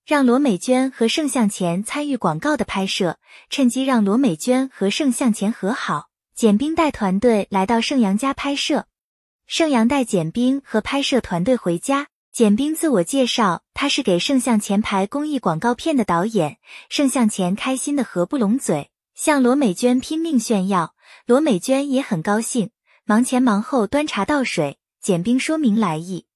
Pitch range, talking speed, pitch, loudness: 200-275 Hz, 255 characters per minute, 245 Hz, -19 LUFS